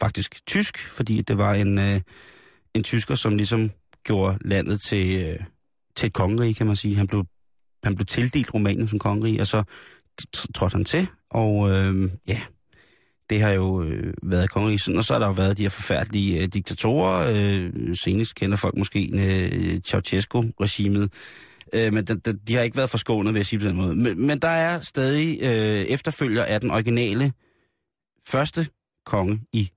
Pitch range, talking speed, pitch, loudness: 100-115 Hz, 175 wpm, 105 Hz, -23 LUFS